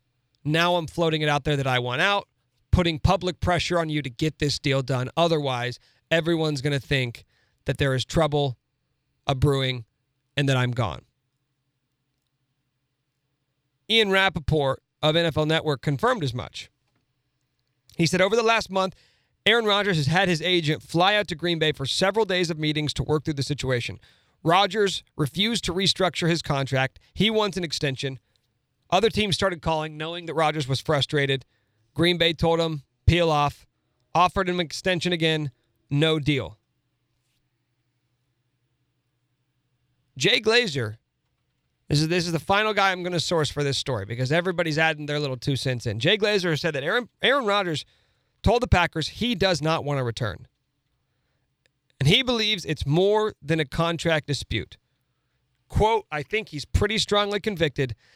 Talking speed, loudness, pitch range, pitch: 165 wpm, -24 LUFS, 130-175 Hz, 145 Hz